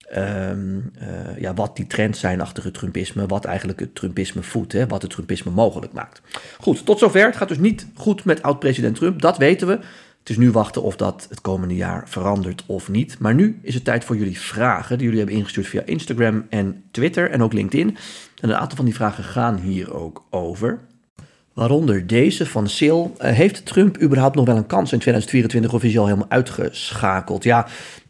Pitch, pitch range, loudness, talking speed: 115 Hz, 100-140 Hz, -20 LUFS, 205 wpm